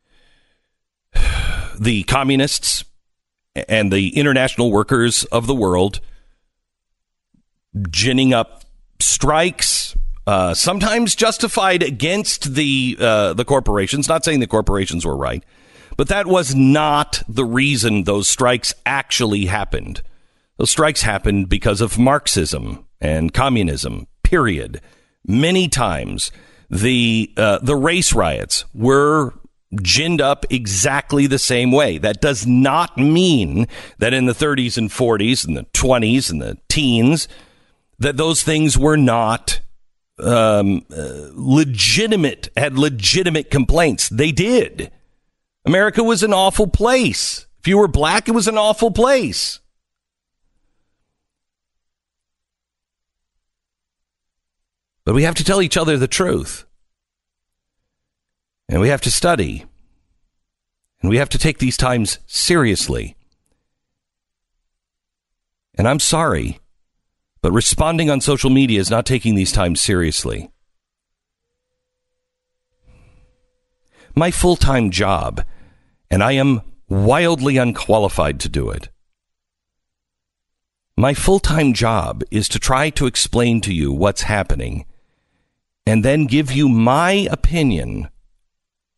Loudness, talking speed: -16 LUFS, 115 wpm